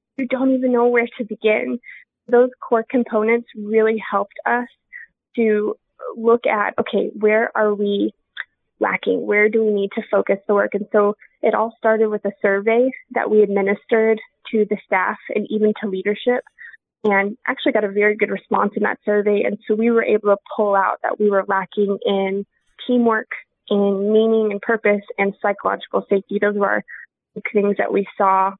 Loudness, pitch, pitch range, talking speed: -19 LUFS, 215 Hz, 205-230 Hz, 180 wpm